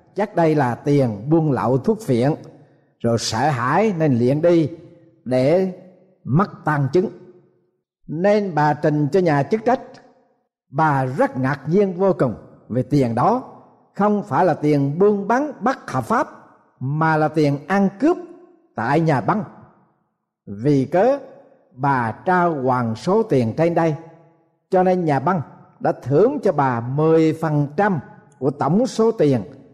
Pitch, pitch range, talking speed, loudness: 165 Hz, 145-195 Hz, 145 wpm, -19 LUFS